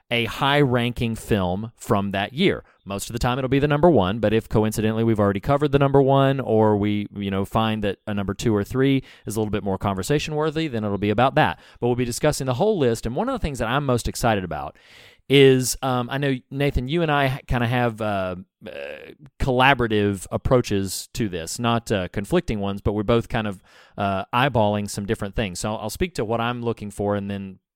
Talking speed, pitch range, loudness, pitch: 225 wpm, 105-130 Hz, -22 LUFS, 115 Hz